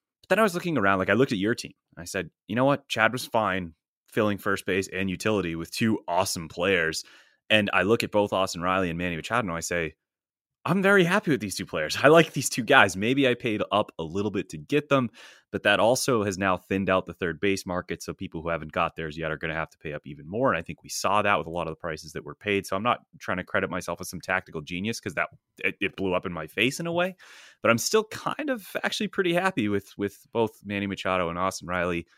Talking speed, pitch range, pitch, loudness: 270 wpm, 90-120 Hz, 100 Hz, -26 LUFS